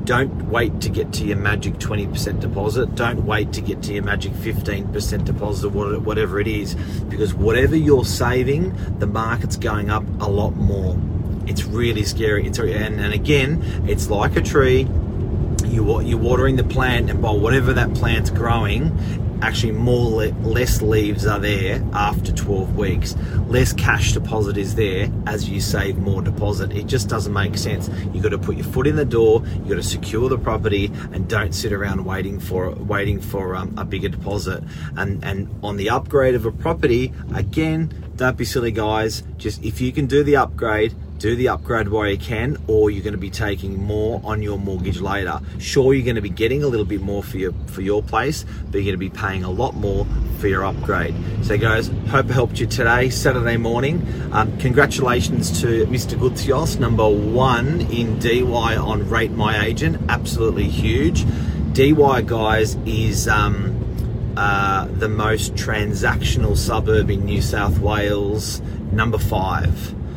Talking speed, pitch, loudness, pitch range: 175 wpm, 105 Hz, -20 LUFS, 100-115 Hz